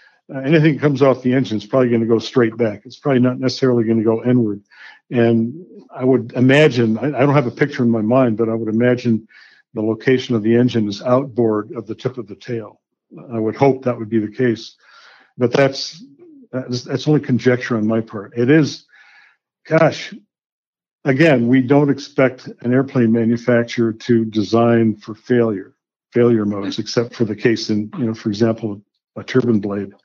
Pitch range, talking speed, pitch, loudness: 115-135 Hz, 185 wpm, 120 Hz, -17 LUFS